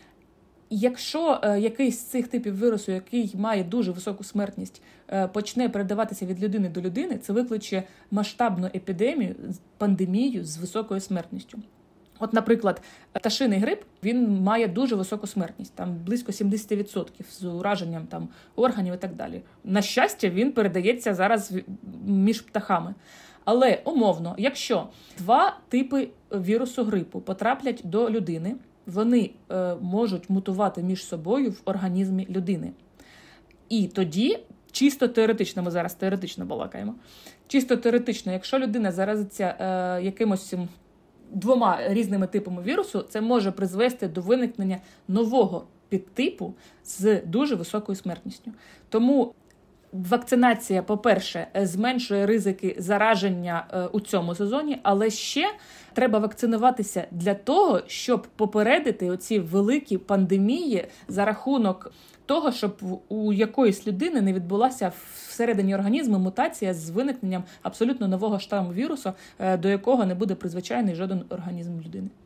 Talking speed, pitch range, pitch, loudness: 120 wpm, 190-235 Hz, 205 Hz, -25 LUFS